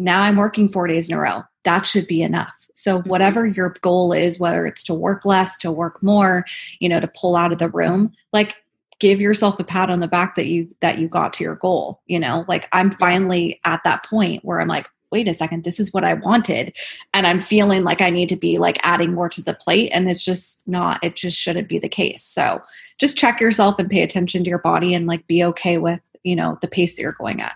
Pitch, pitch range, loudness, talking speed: 180 Hz, 170-195 Hz, -18 LUFS, 250 wpm